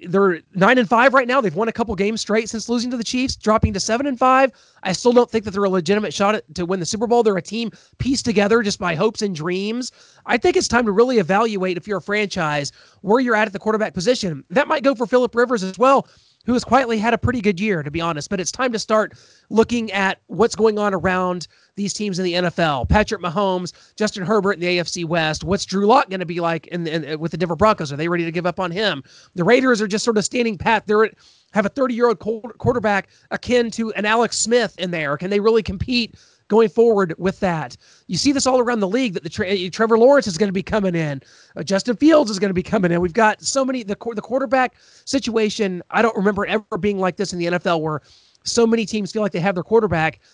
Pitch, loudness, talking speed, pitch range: 210 Hz, -19 LUFS, 250 wpm, 185-230 Hz